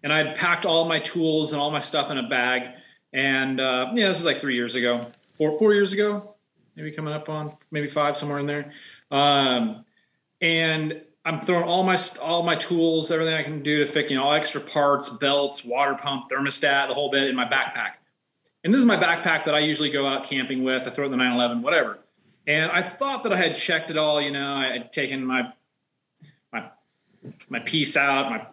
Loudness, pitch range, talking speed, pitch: -23 LUFS, 135-160 Hz, 225 wpm, 150 Hz